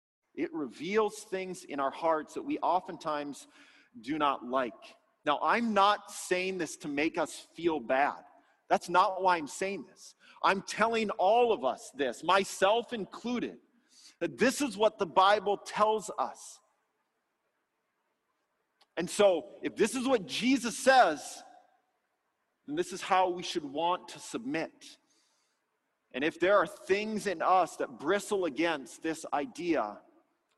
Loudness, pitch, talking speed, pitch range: -30 LUFS, 205 Hz, 145 wpm, 180-265 Hz